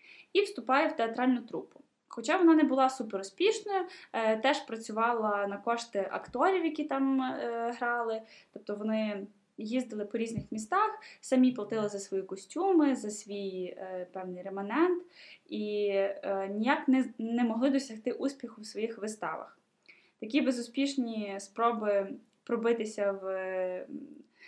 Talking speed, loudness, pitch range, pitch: 130 wpm, -31 LUFS, 205-275 Hz, 235 Hz